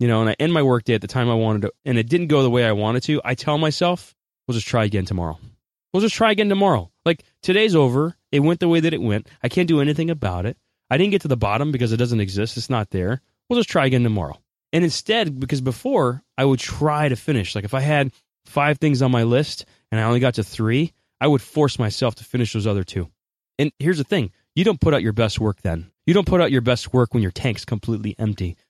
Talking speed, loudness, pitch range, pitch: 265 wpm, -20 LUFS, 110-150 Hz, 125 Hz